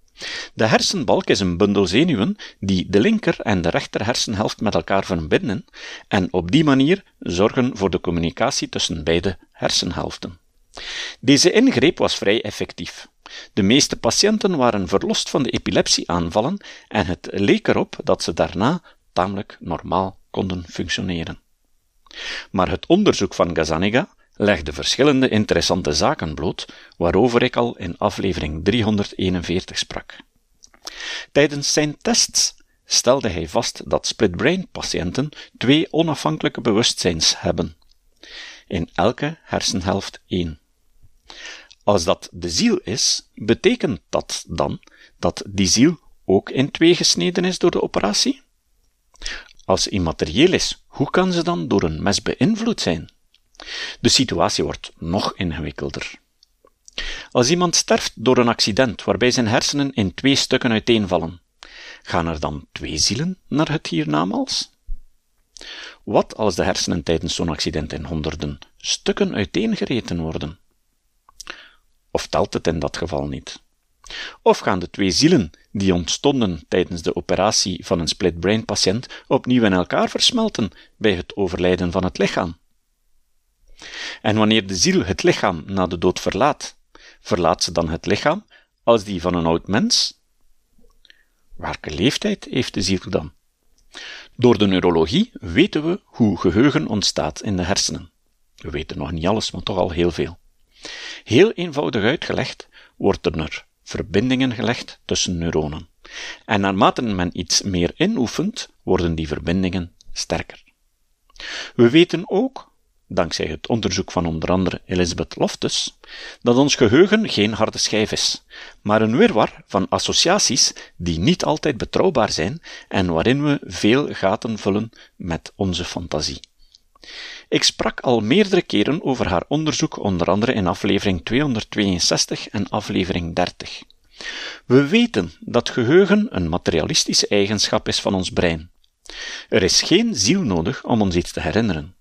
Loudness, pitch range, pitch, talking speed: -19 LUFS, 85-130 Hz, 100 Hz, 140 wpm